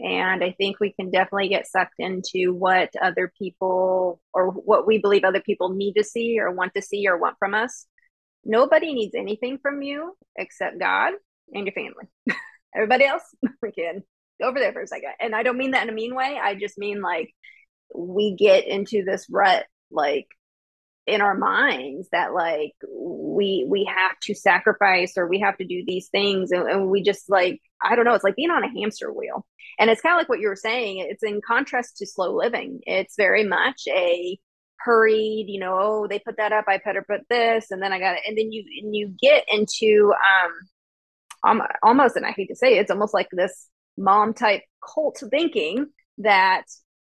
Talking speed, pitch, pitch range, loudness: 205 wpm, 205 Hz, 190-240 Hz, -22 LUFS